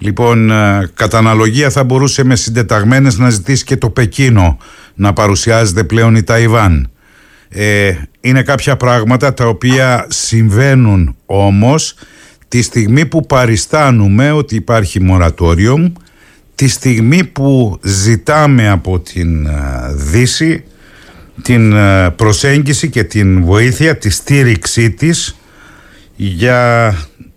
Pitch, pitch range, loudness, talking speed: 115 Hz, 100-130 Hz, -10 LUFS, 100 wpm